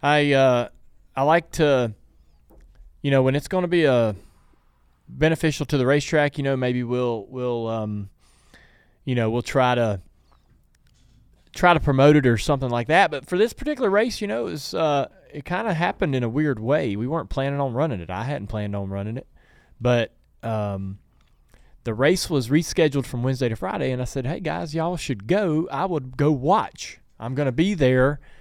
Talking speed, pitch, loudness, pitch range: 195 wpm, 135 Hz, -22 LUFS, 120-155 Hz